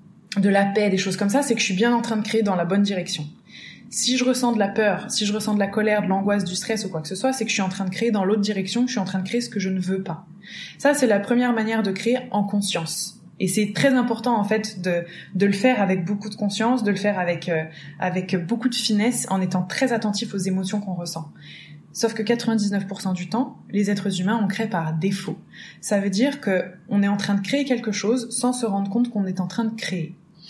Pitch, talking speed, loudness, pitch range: 205 Hz, 270 wpm, -23 LUFS, 190-225 Hz